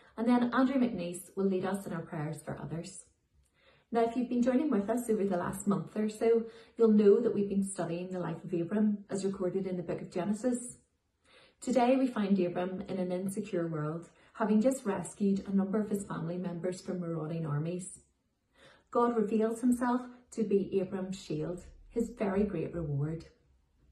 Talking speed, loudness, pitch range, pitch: 185 wpm, -32 LUFS, 175-225 Hz, 195 Hz